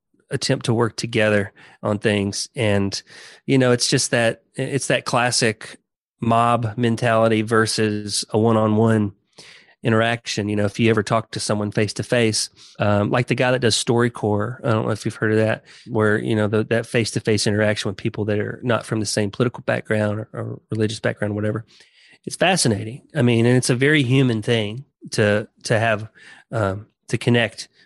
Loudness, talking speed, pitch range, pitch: -20 LUFS, 190 wpm, 105-120 Hz, 115 Hz